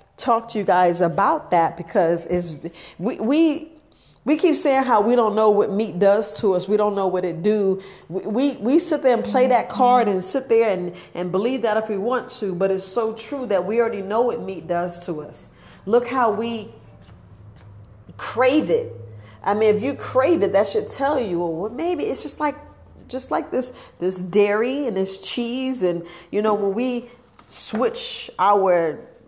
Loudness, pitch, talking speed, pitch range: -21 LUFS, 210 Hz, 195 wpm, 180-250 Hz